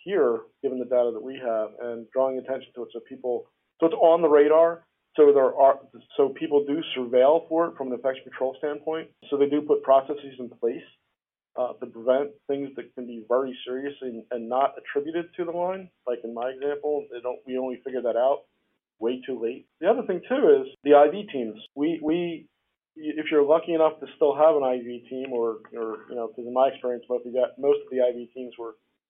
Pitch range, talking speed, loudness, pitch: 125-160 Hz, 215 wpm, -25 LUFS, 135 Hz